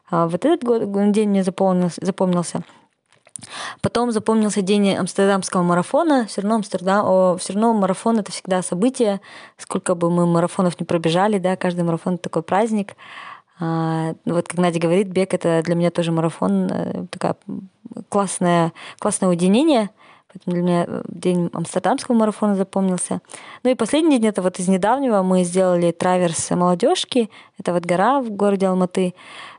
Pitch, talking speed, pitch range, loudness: 190 Hz, 140 wpm, 175-215 Hz, -19 LUFS